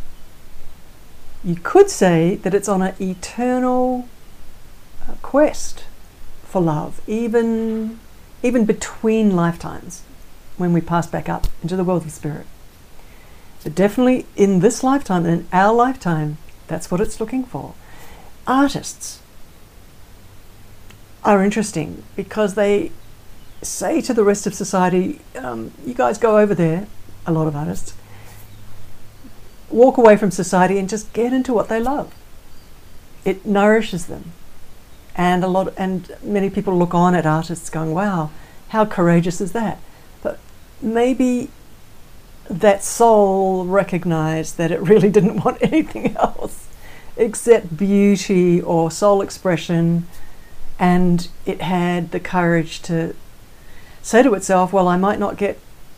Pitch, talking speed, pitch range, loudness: 190 Hz, 130 wpm, 170-220 Hz, -18 LUFS